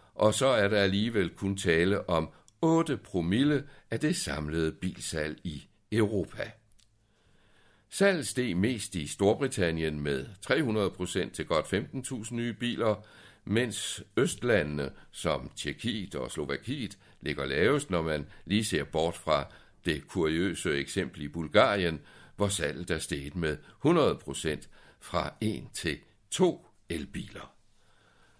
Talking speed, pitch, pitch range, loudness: 125 wpm, 100 Hz, 80-115 Hz, -30 LUFS